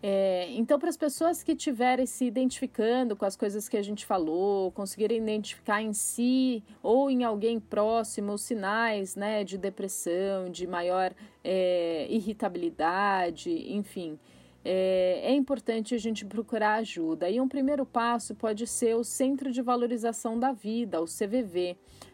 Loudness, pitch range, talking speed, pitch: -29 LUFS, 195-245 Hz, 150 wpm, 220 Hz